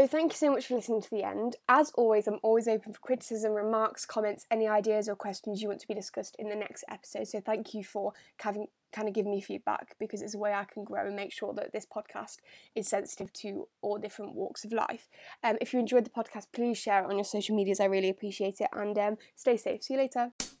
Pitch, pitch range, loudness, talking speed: 215 Hz, 205-230 Hz, -32 LUFS, 255 wpm